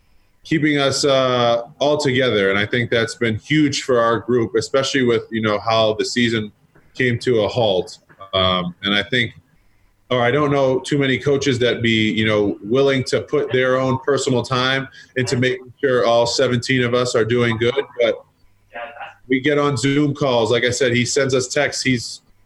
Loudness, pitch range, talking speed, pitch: -18 LUFS, 110-135 Hz, 190 wpm, 125 Hz